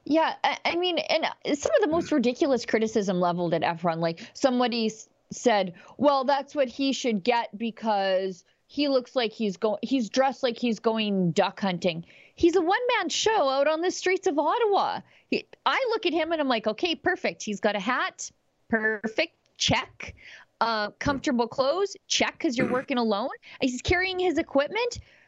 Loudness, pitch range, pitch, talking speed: -26 LUFS, 215-325 Hz, 255 Hz, 175 wpm